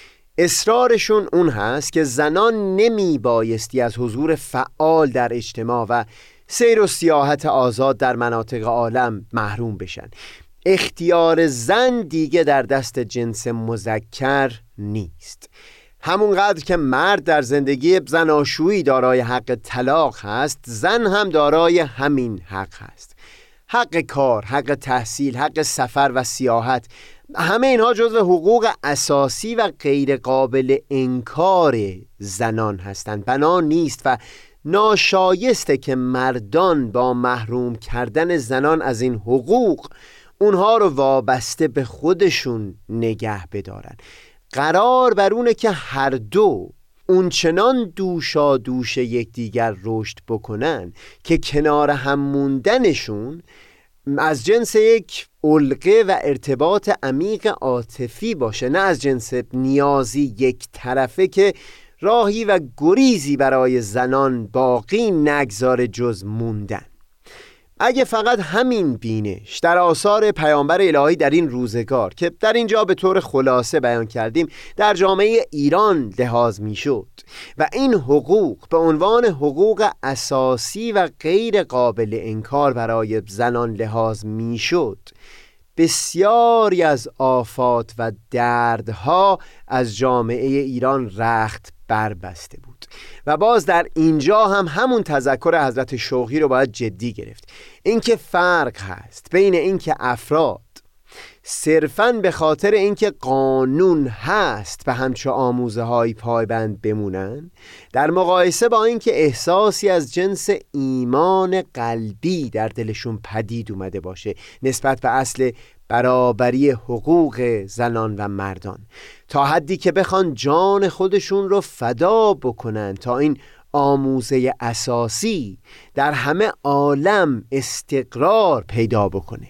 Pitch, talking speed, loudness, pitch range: 135 Hz, 115 wpm, -18 LUFS, 120-180 Hz